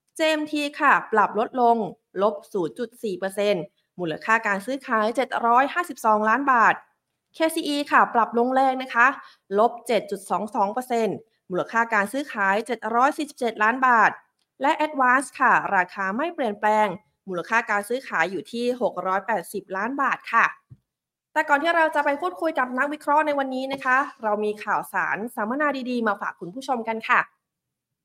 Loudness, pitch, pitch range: -23 LUFS, 235 Hz, 210-275 Hz